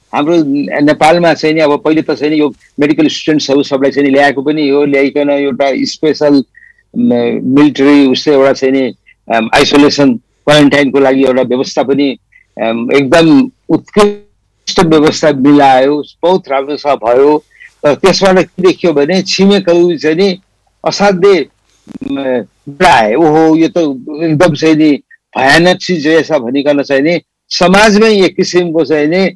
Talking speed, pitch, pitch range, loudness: 135 wpm, 150 Hz, 140-180 Hz, -9 LUFS